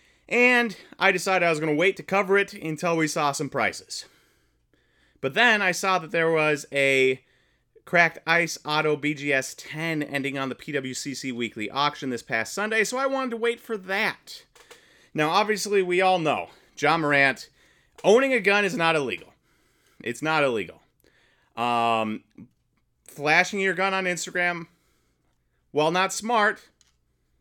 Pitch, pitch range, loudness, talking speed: 165 Hz, 140-195 Hz, -23 LUFS, 155 wpm